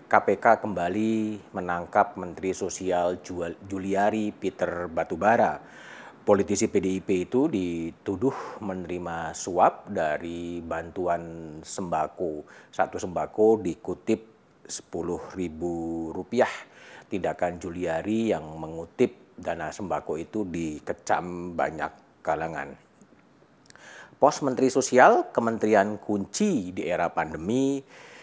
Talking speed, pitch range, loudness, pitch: 85 wpm, 85-105 Hz, -27 LUFS, 90 Hz